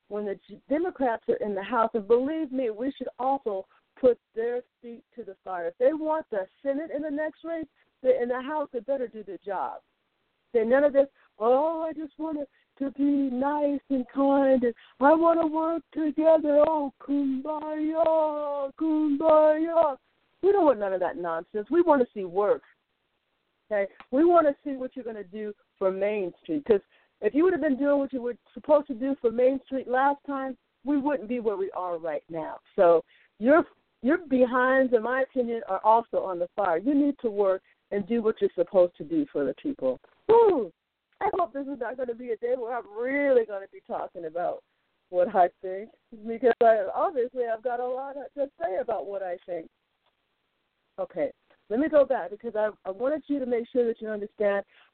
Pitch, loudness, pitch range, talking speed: 265 Hz, -26 LUFS, 220-300 Hz, 205 wpm